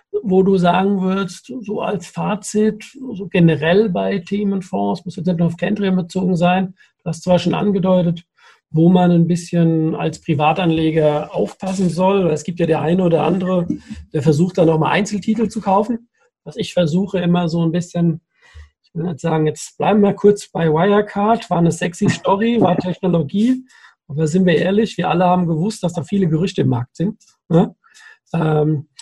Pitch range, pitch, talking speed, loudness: 165-200 Hz, 180 Hz, 180 wpm, -17 LUFS